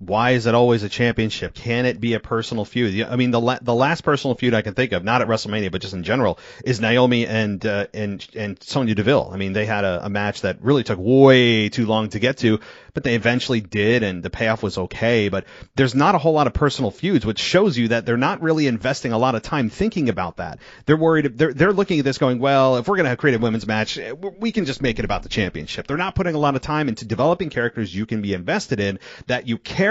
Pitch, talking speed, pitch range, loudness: 120 Hz, 265 wpm, 110-135 Hz, -20 LUFS